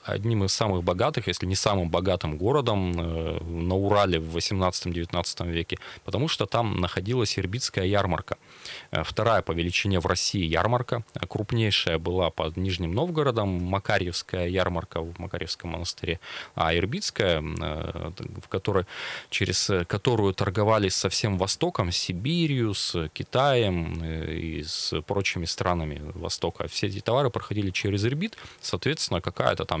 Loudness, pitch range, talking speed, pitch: -27 LUFS, 85-110 Hz, 125 wpm, 95 Hz